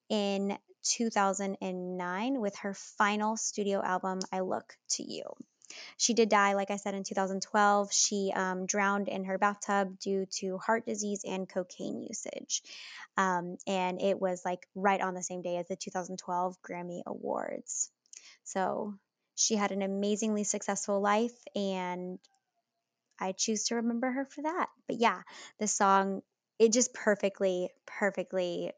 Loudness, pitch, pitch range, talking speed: -32 LUFS, 200 Hz, 185-215 Hz, 145 wpm